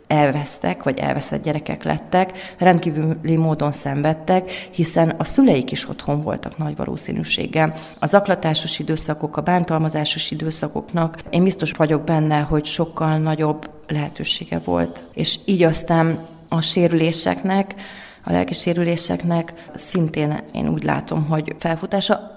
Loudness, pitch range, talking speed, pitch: -20 LUFS, 150-175 Hz, 120 wpm, 160 Hz